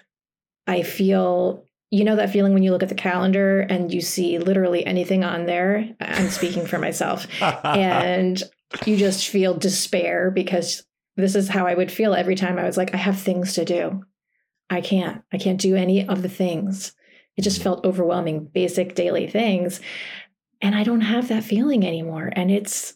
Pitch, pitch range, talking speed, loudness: 185 Hz, 180-195 Hz, 185 wpm, -21 LUFS